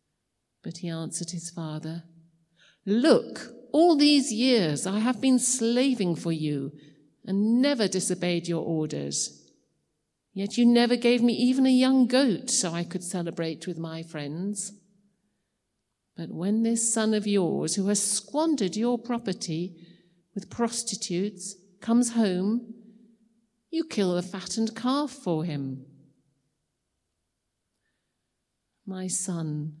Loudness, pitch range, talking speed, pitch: -26 LUFS, 165-230 Hz, 120 wpm, 190 Hz